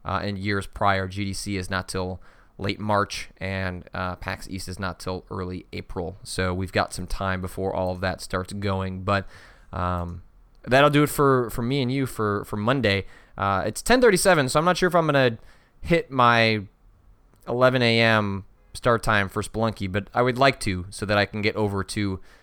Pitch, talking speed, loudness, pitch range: 100 Hz, 195 wpm, -24 LUFS, 95-115 Hz